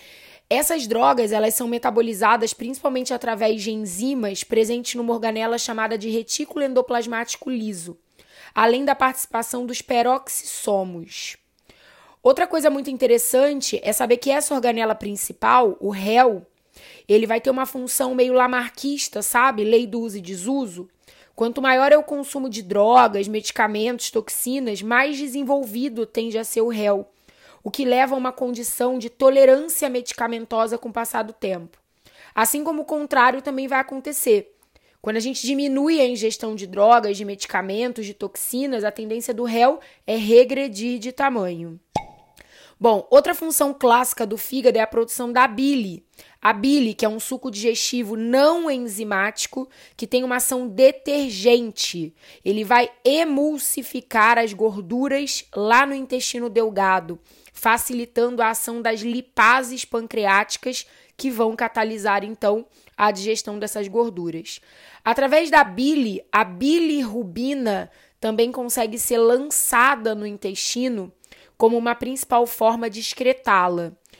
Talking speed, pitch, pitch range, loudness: 135 wpm, 235 Hz, 220-265 Hz, -20 LUFS